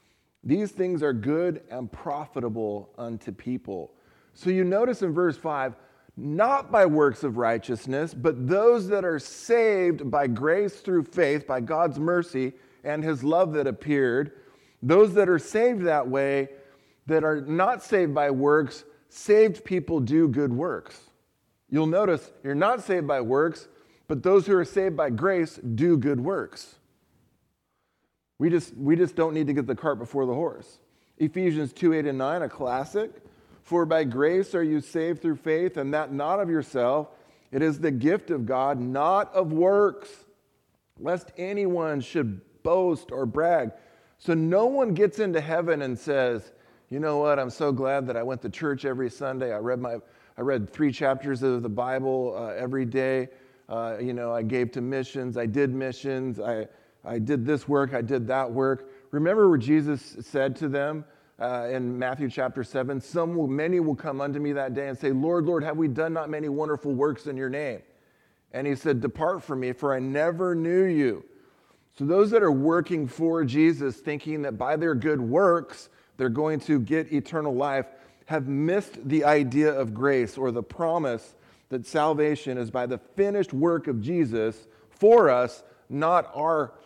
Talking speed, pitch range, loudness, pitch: 180 wpm, 130-165 Hz, -25 LUFS, 145 Hz